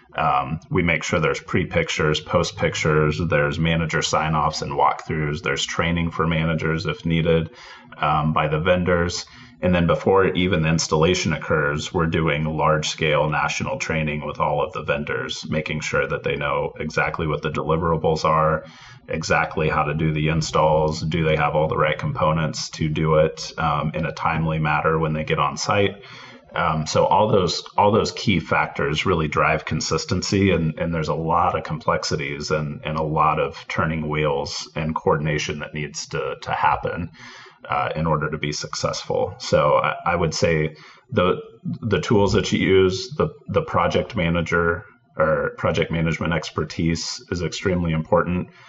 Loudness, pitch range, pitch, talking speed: -21 LUFS, 75-85 Hz, 80 Hz, 170 wpm